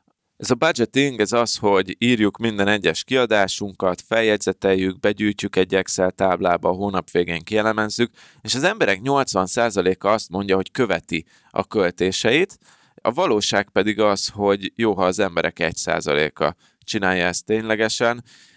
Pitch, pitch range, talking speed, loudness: 105 Hz, 95-115 Hz, 135 wpm, -20 LUFS